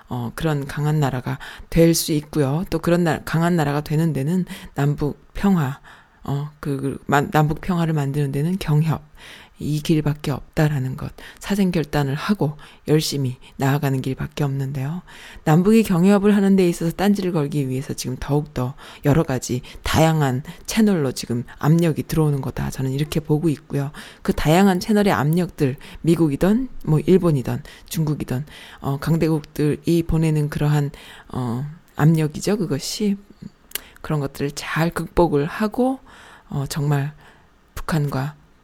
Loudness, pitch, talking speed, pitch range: -21 LUFS, 150 Hz, 295 characters per minute, 140-170 Hz